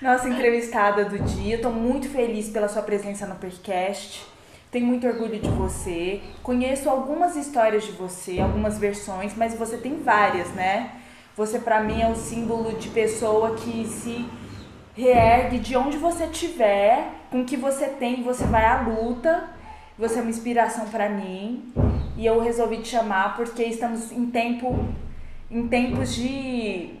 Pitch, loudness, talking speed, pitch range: 230 Hz, -24 LUFS, 160 wpm, 215-245 Hz